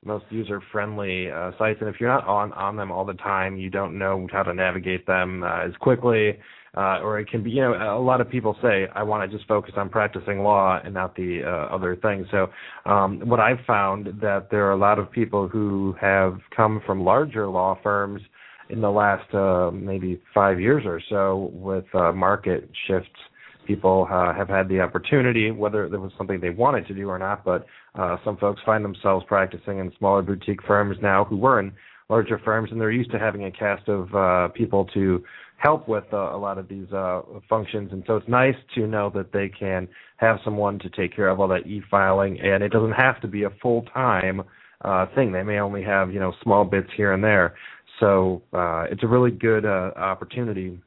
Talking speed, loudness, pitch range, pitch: 215 wpm, -23 LUFS, 95-105 Hz, 100 Hz